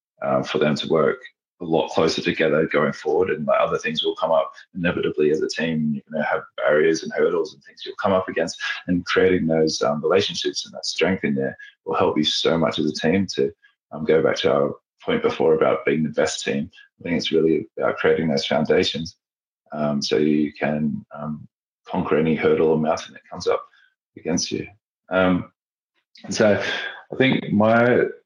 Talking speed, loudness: 205 wpm, -21 LUFS